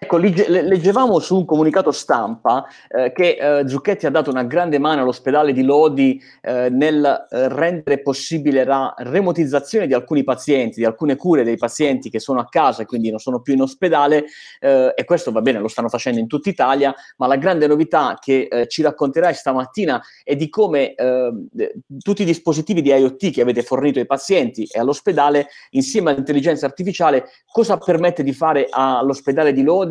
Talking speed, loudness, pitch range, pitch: 180 wpm, -17 LUFS, 130-160 Hz, 145 Hz